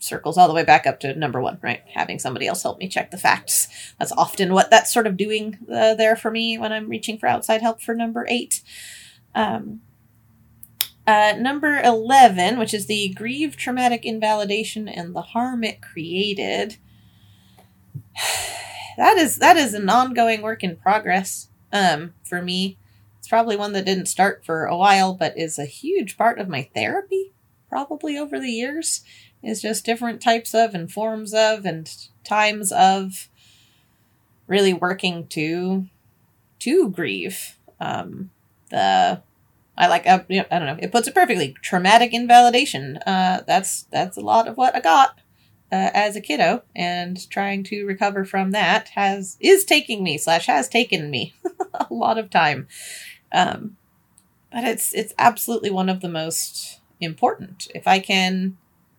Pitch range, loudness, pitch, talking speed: 175-230 Hz, -20 LUFS, 205 Hz, 165 wpm